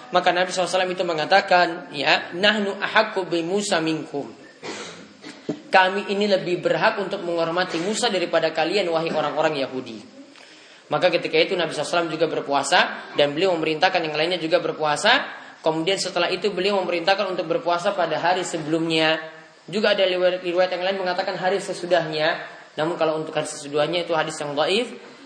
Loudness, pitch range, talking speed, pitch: -22 LUFS, 160-190 Hz, 150 wpm, 175 Hz